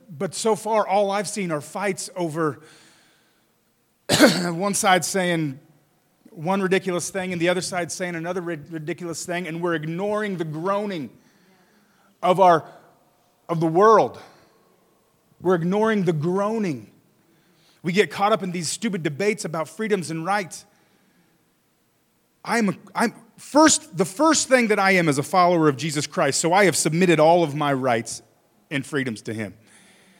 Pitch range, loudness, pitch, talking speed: 165-200 Hz, -22 LUFS, 180 Hz, 155 wpm